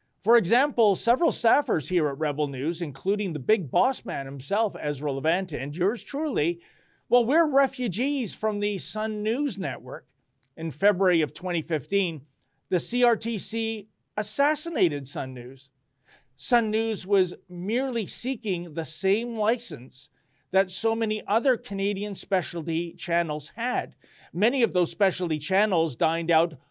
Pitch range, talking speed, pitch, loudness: 155-225 Hz, 135 wpm, 190 Hz, -26 LUFS